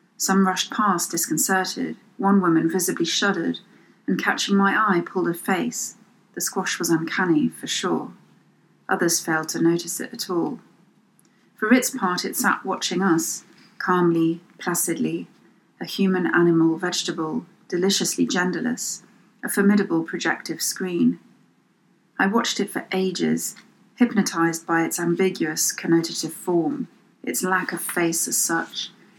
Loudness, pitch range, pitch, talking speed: -22 LUFS, 170-205 Hz, 185 Hz, 130 wpm